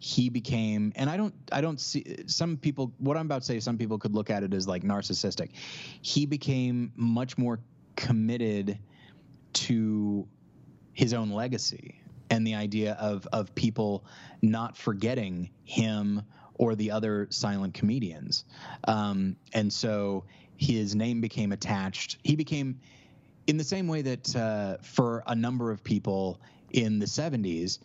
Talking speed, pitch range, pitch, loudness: 150 wpm, 105-135 Hz, 115 Hz, -30 LUFS